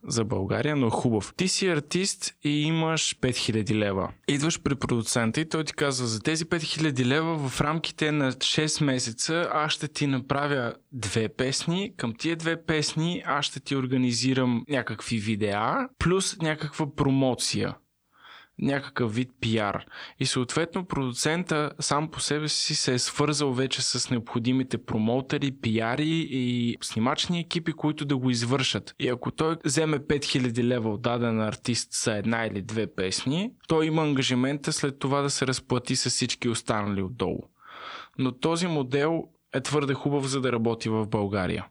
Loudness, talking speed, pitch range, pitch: -27 LUFS, 155 wpm, 120-155 Hz, 135 Hz